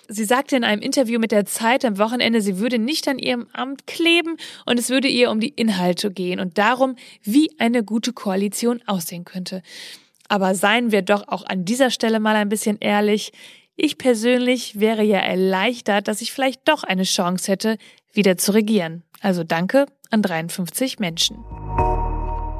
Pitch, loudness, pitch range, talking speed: 220 Hz, -20 LUFS, 195-250 Hz, 175 wpm